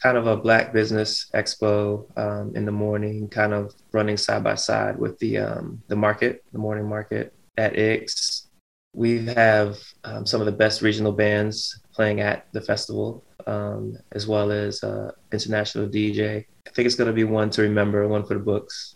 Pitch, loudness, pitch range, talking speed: 105 Hz, -23 LUFS, 105-110 Hz, 185 wpm